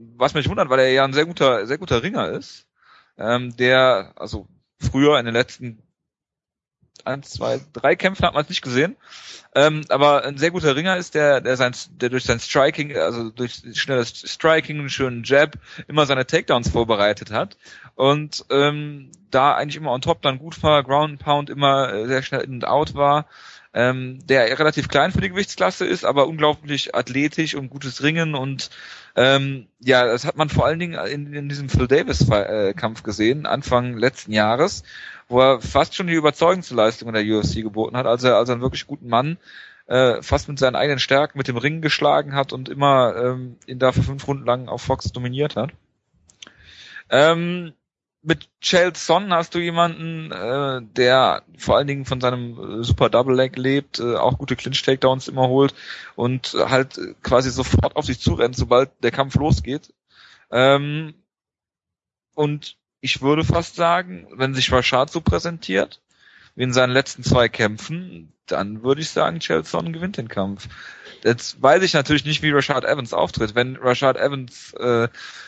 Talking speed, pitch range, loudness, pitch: 180 wpm, 125-150 Hz, -20 LUFS, 135 Hz